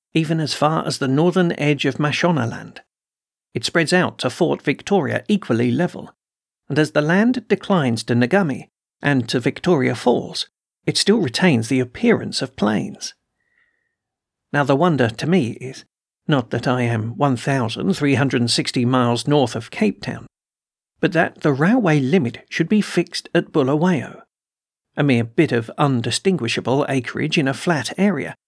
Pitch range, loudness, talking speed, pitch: 125-175 Hz, -19 LUFS, 150 wpm, 145 Hz